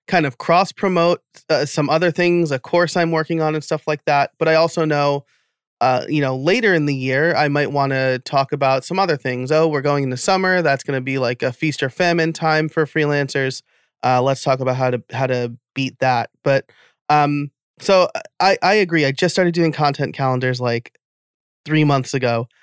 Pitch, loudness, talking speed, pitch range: 145 Hz, -18 LUFS, 210 wpm, 135-160 Hz